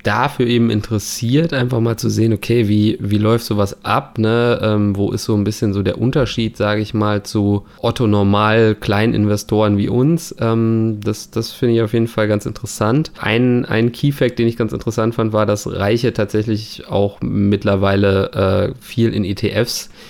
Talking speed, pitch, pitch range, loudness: 175 wpm, 110 Hz, 105-115 Hz, -17 LUFS